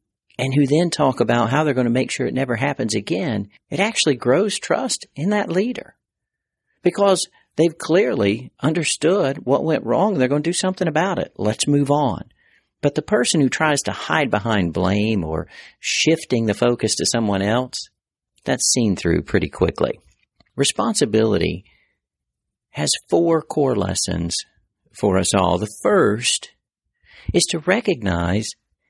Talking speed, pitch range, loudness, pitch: 150 wpm, 105-160 Hz, -20 LUFS, 130 Hz